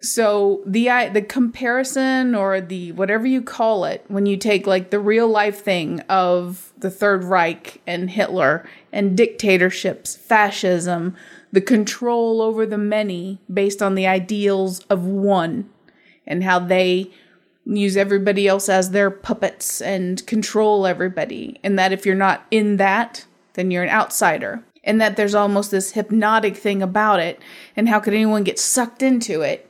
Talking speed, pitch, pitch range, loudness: 160 wpm, 200 Hz, 190-220 Hz, -19 LUFS